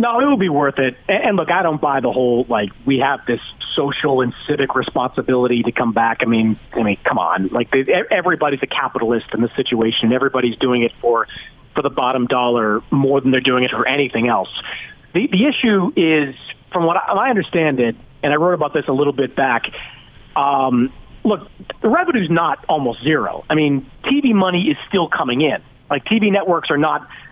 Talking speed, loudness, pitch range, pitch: 200 wpm, -17 LUFS, 120-160 Hz, 135 Hz